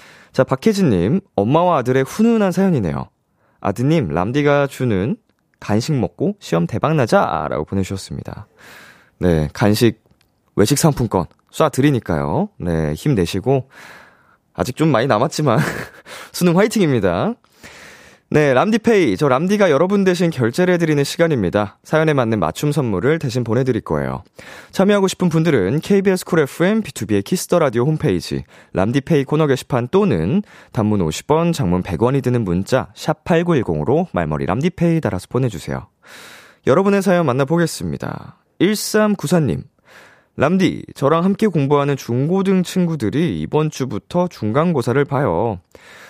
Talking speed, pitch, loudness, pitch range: 310 characters per minute, 140 Hz, -17 LUFS, 105-175 Hz